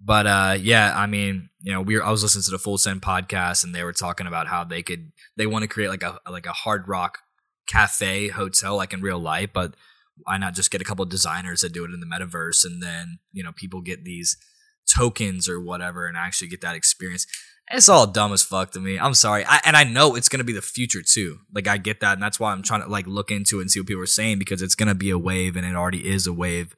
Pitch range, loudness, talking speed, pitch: 90-105 Hz, -20 LUFS, 275 wpm, 95 Hz